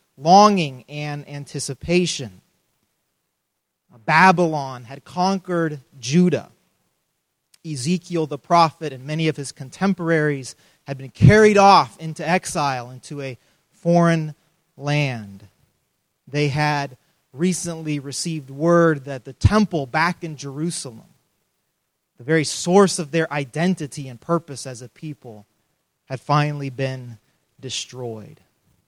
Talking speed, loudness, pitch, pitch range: 105 wpm, -20 LUFS, 150 Hz, 135-170 Hz